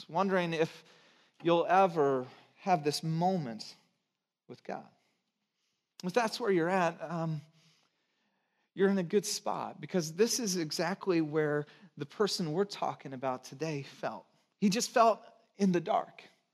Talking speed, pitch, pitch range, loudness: 140 wpm, 170 Hz, 160-195 Hz, -32 LUFS